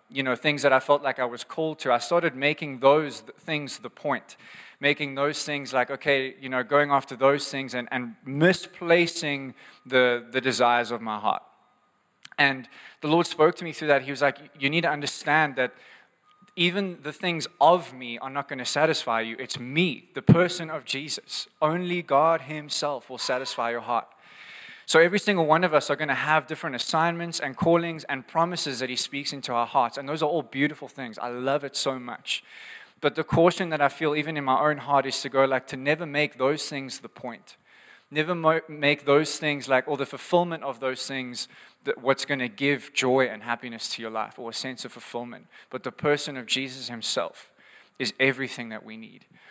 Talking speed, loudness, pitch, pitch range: 205 wpm, -25 LUFS, 140 Hz, 130-155 Hz